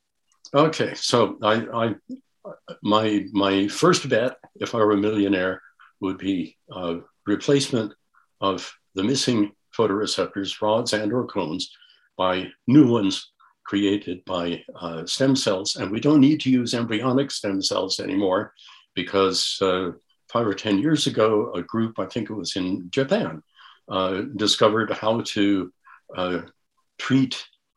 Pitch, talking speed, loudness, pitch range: 100 Hz, 140 wpm, -23 LUFS, 95-115 Hz